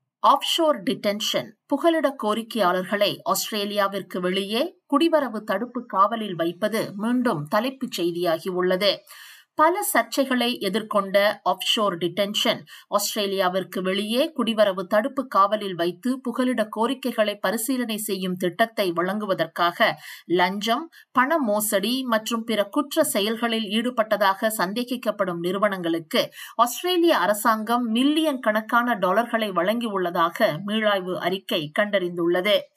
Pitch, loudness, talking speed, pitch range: 215 Hz, -23 LUFS, 90 wpm, 195-250 Hz